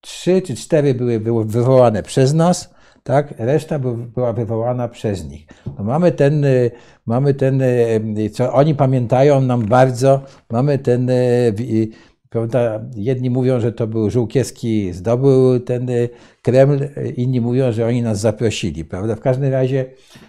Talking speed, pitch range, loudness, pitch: 135 wpm, 115-135 Hz, -17 LUFS, 125 Hz